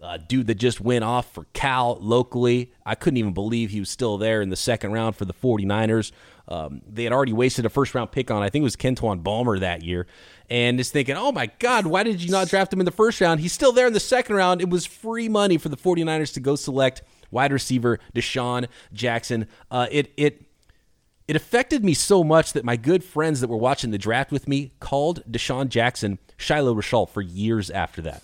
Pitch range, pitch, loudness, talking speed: 115-155 Hz, 125 Hz, -22 LUFS, 225 wpm